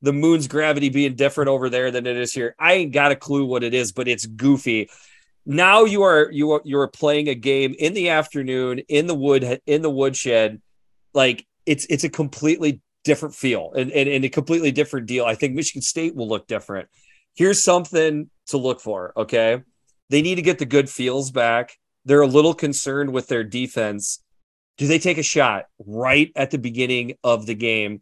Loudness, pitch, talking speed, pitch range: -20 LUFS, 140 Hz, 205 wpm, 125-150 Hz